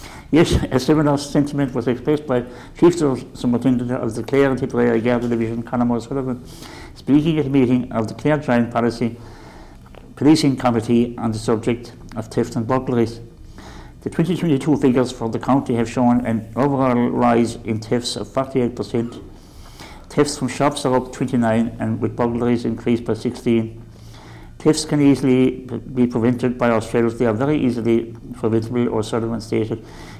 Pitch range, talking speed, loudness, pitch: 115-130 Hz, 155 wpm, -19 LUFS, 120 Hz